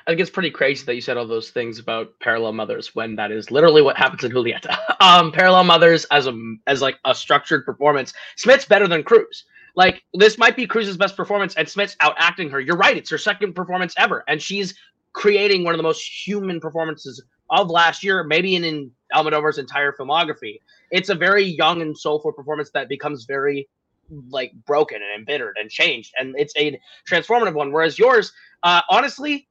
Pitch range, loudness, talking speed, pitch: 140-200 Hz, -18 LUFS, 200 wpm, 165 Hz